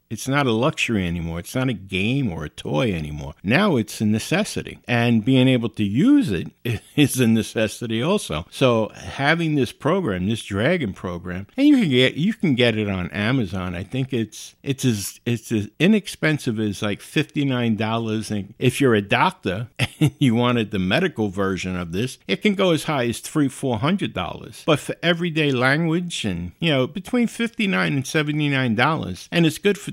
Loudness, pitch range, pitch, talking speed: -21 LUFS, 105-155 Hz, 125 Hz, 195 wpm